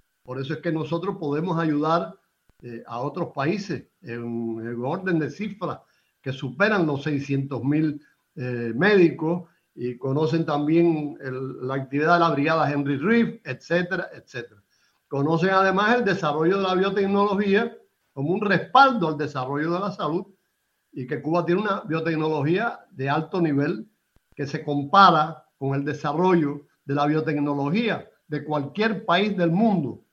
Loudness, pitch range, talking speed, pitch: -23 LUFS, 140-180 Hz, 145 wpm, 155 Hz